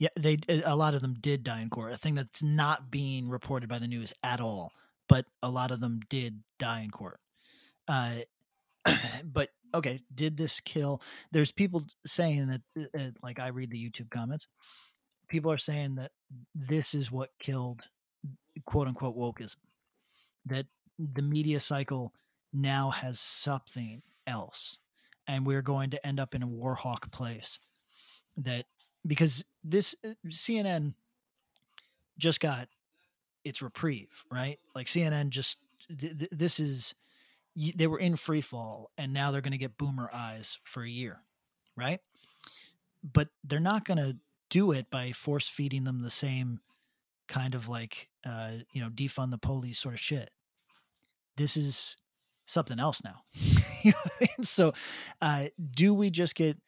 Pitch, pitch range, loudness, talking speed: 140 Hz, 125-155 Hz, -32 LUFS, 155 wpm